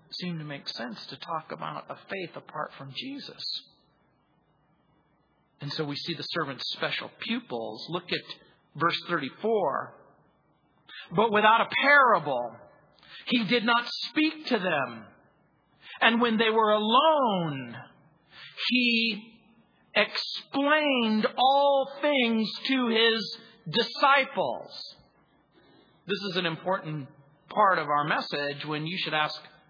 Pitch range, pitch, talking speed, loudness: 155-240 Hz, 205 Hz, 115 wpm, -26 LUFS